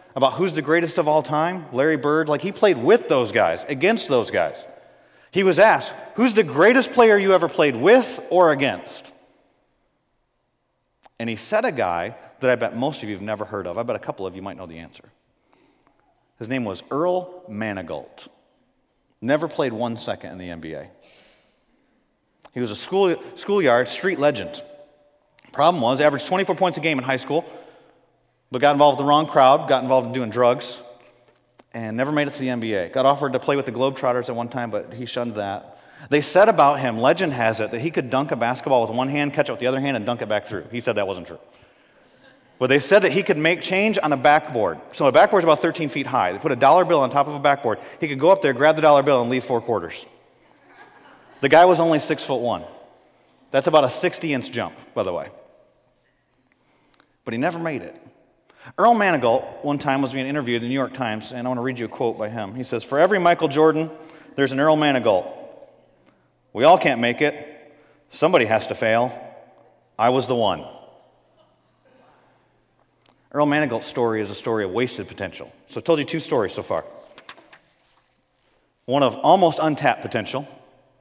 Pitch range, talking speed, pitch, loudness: 125-160 Hz, 205 wpm, 140 Hz, -20 LUFS